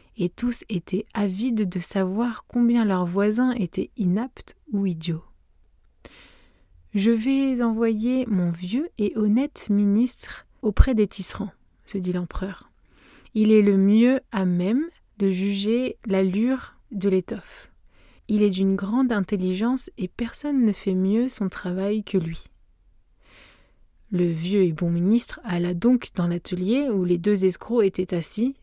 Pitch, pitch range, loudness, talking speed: 200 Hz, 180-230 Hz, -23 LUFS, 140 wpm